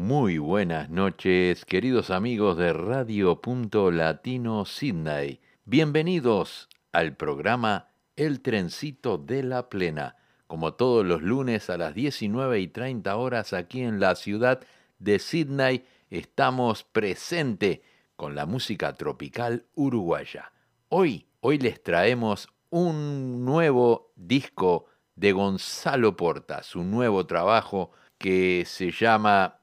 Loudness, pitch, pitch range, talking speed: -26 LUFS, 115 Hz, 95-130 Hz, 115 wpm